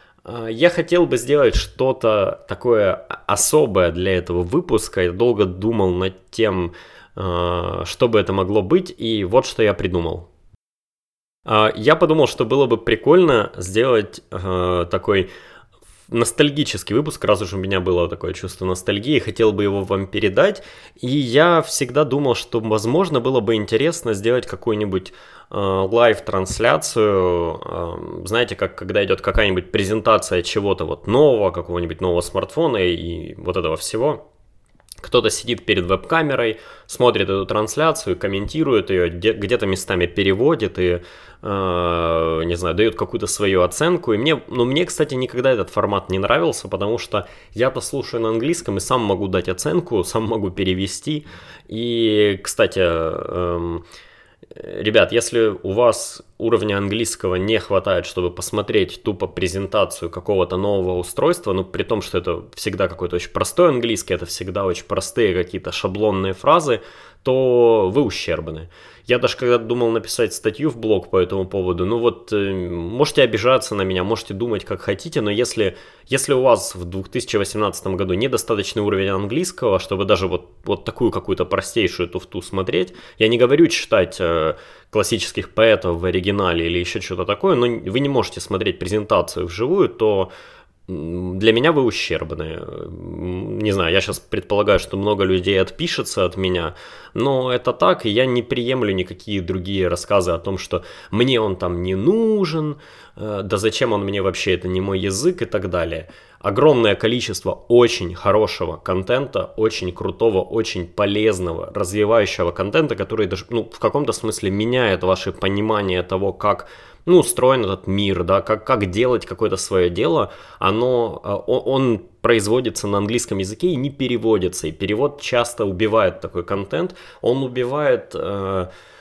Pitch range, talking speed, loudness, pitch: 95-120 Hz, 150 wpm, -19 LUFS, 100 Hz